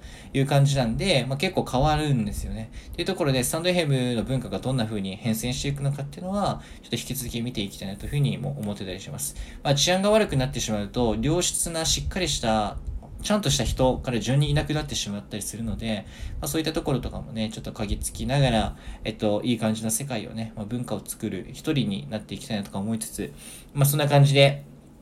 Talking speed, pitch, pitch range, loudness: 490 characters per minute, 120 Hz, 105-140 Hz, -25 LUFS